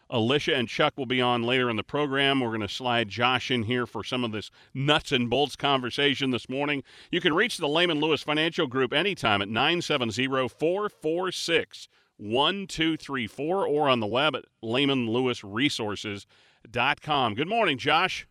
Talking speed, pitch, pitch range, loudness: 160 wpm, 130 Hz, 120-150 Hz, -26 LUFS